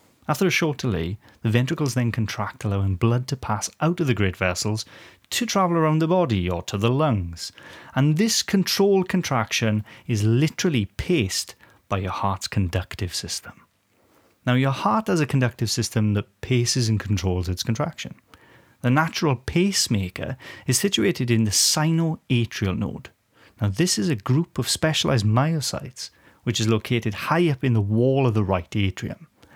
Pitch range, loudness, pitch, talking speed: 105-150 Hz, -23 LUFS, 115 Hz, 160 wpm